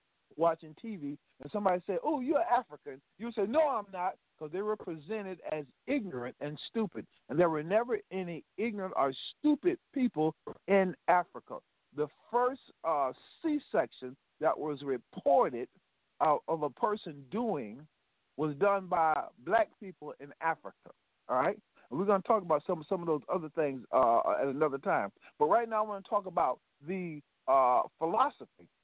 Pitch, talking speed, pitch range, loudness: 185 Hz, 165 wpm, 155-220 Hz, -32 LUFS